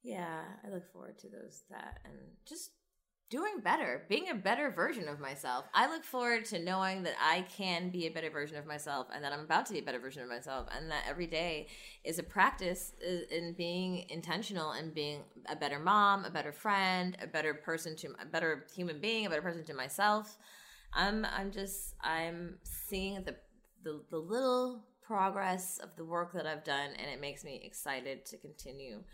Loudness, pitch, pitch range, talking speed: -36 LUFS, 175 Hz, 155-195 Hz, 200 wpm